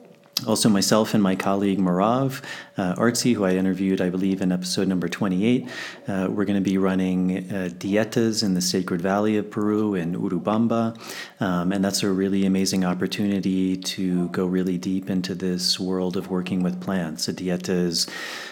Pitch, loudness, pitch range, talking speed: 95 Hz, -23 LUFS, 90-100 Hz, 170 wpm